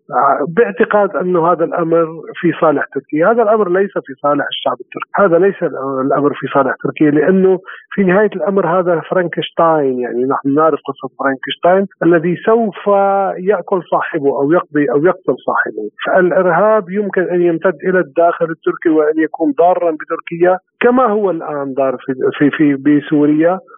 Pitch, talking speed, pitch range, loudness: 170 Hz, 150 wpm, 150-195 Hz, -14 LUFS